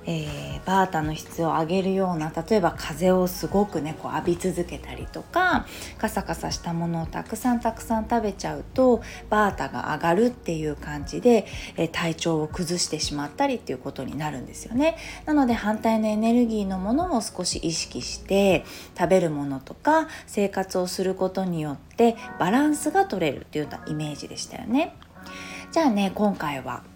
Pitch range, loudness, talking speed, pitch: 160-230 Hz, -25 LUFS, 365 characters per minute, 190 Hz